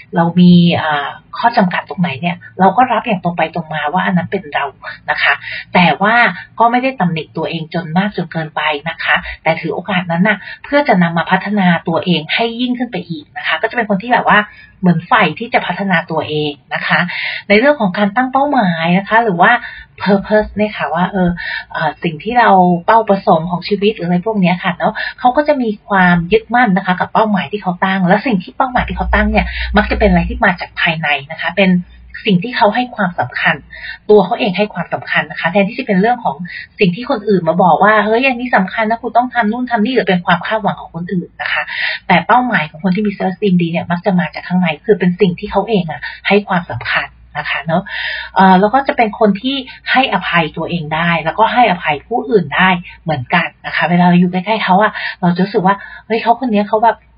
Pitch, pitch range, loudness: 195 Hz, 175-225 Hz, -14 LUFS